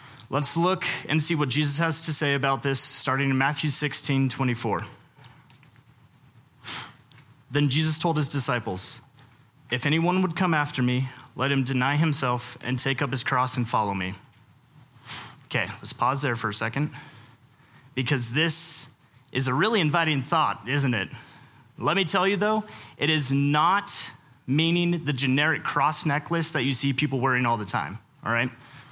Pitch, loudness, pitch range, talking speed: 135 Hz, -22 LUFS, 125-150 Hz, 160 wpm